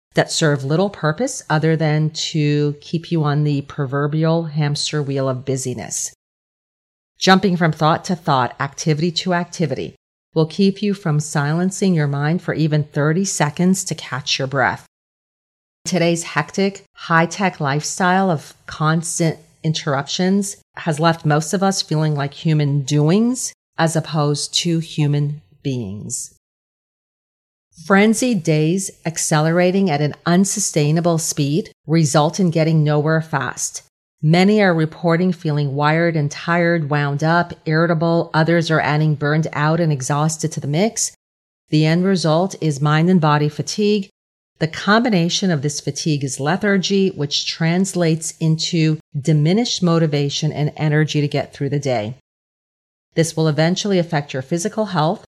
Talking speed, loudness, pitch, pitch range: 140 wpm, -18 LUFS, 160 Hz, 145-175 Hz